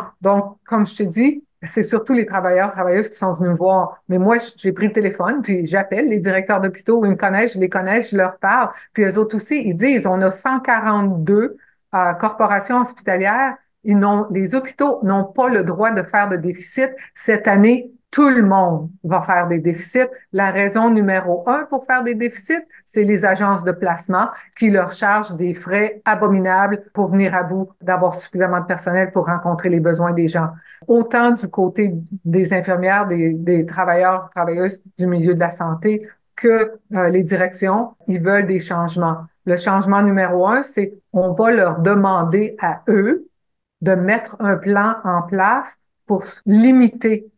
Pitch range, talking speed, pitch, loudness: 185-220 Hz, 180 wpm, 195 Hz, -17 LUFS